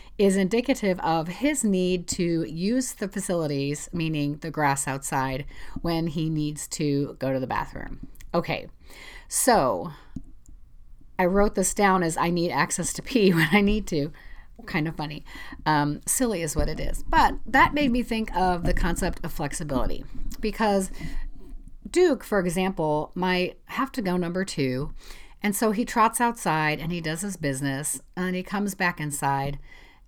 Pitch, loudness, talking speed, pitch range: 175 Hz, -25 LUFS, 160 wpm, 150-200 Hz